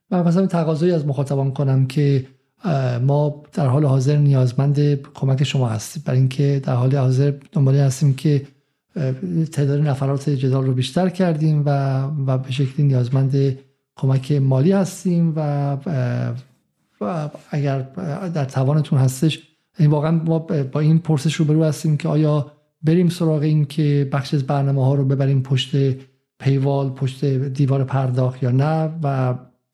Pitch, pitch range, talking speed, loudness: 140 Hz, 135-155 Hz, 145 wpm, -19 LUFS